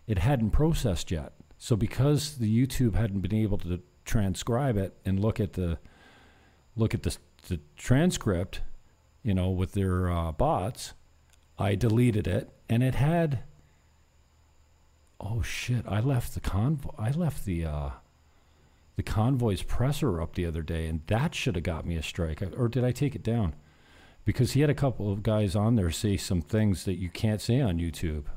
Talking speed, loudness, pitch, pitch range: 180 wpm, -29 LUFS, 100 Hz, 80-120 Hz